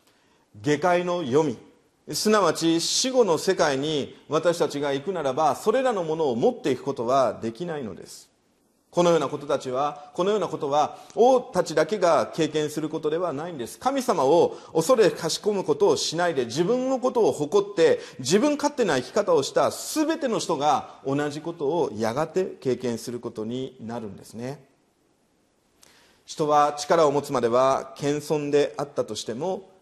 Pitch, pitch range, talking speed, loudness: 165 Hz, 145-240 Hz, 310 characters per minute, -24 LUFS